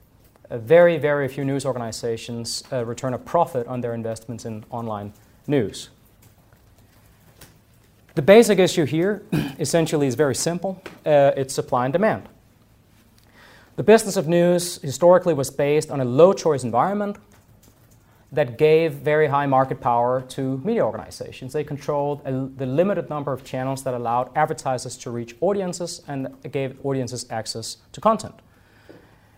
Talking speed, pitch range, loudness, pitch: 145 wpm, 120-155 Hz, -21 LUFS, 135 Hz